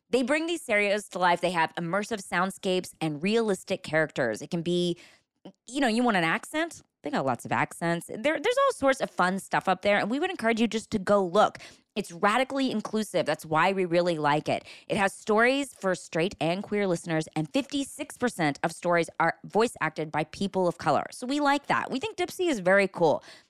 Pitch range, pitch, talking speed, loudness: 170-240 Hz, 195 Hz, 210 wpm, -27 LUFS